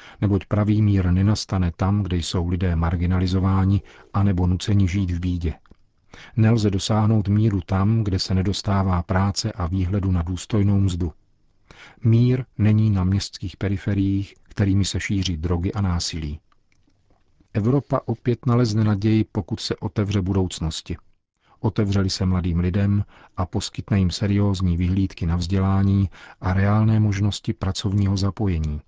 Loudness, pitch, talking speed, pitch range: -22 LUFS, 100 Hz, 130 wpm, 90-105 Hz